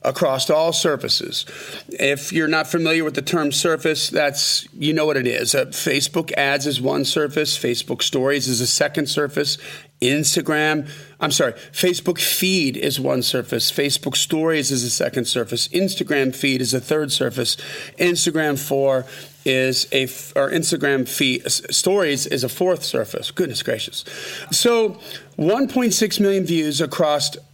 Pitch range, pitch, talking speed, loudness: 135-165 Hz, 150 Hz, 150 wpm, -19 LUFS